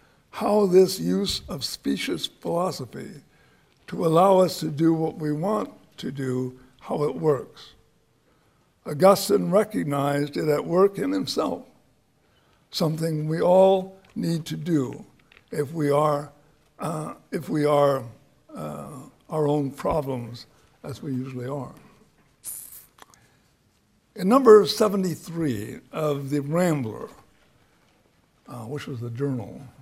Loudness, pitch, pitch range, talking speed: -24 LUFS, 150 Hz, 130-170 Hz, 115 wpm